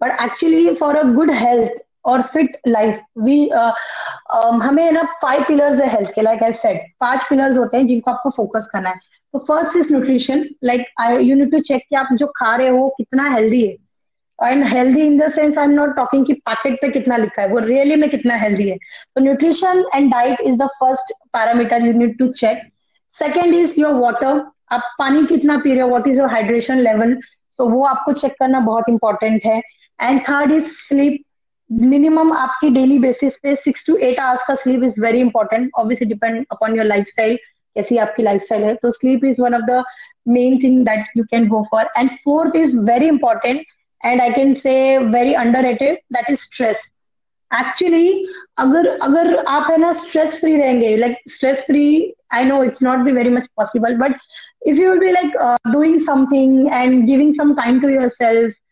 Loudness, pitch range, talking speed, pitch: -15 LUFS, 235-290 Hz, 200 wpm, 260 Hz